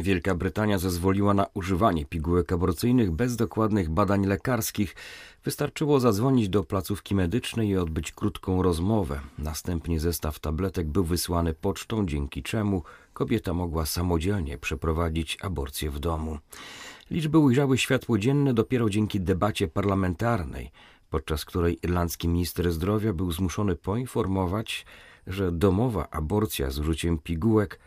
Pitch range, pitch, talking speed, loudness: 85-105 Hz, 95 Hz, 125 wpm, -27 LUFS